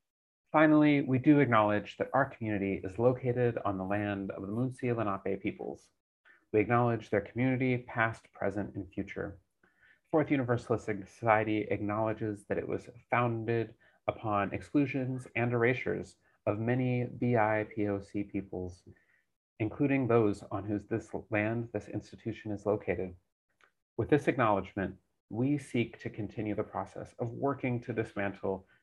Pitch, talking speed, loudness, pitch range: 110 Hz, 135 wpm, -32 LUFS, 100-125 Hz